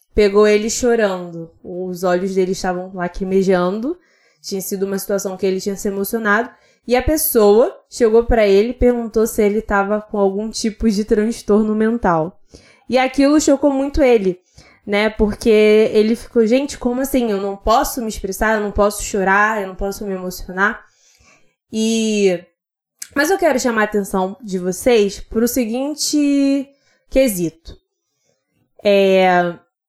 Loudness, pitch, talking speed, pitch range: -17 LUFS, 215 Hz, 150 wpm, 195-240 Hz